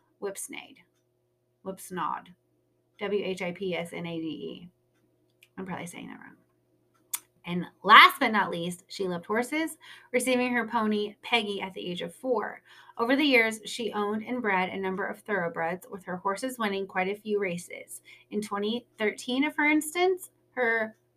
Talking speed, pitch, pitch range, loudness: 160 wpm, 200 Hz, 175-235 Hz, -27 LUFS